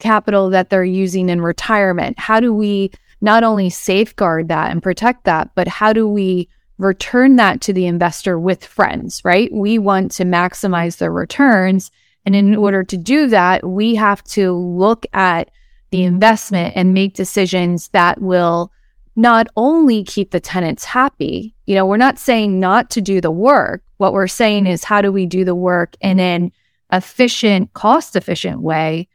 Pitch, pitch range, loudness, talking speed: 195 Hz, 180-215 Hz, -14 LUFS, 175 wpm